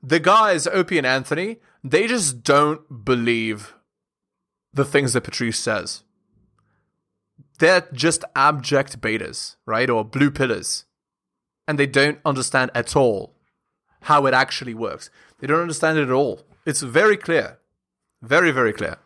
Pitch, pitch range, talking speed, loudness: 140 Hz, 130-160 Hz, 140 wpm, -20 LUFS